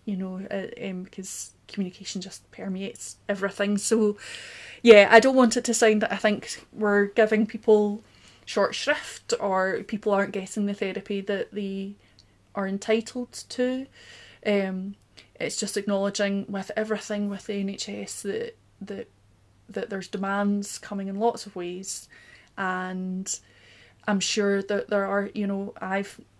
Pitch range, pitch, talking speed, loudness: 195-215 Hz, 200 Hz, 145 wpm, -25 LUFS